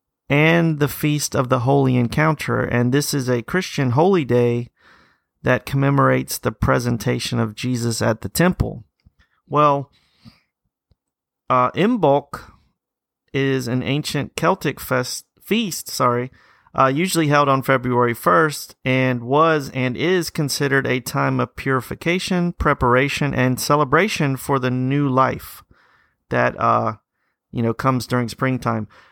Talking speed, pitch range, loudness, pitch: 130 wpm, 125-150 Hz, -19 LUFS, 135 Hz